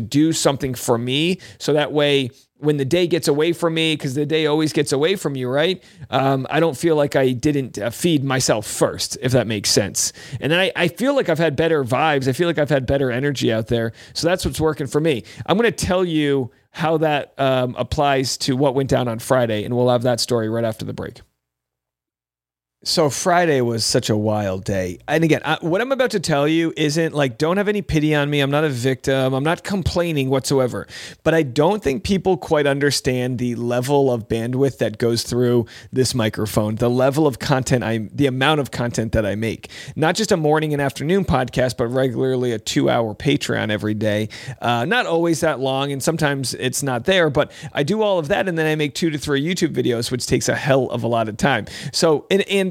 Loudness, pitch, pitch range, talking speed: -19 LUFS, 135 Hz, 120-155 Hz, 225 wpm